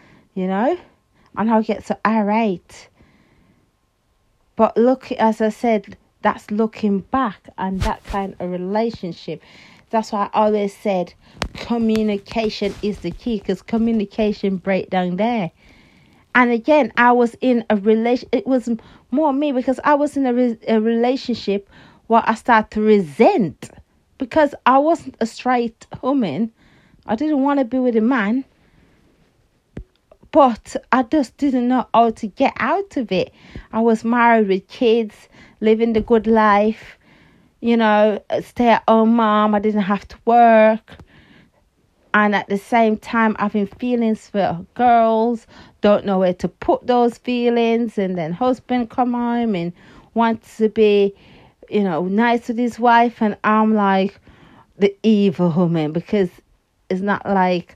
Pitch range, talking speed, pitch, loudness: 205-240 Hz, 150 wpm, 220 Hz, -18 LUFS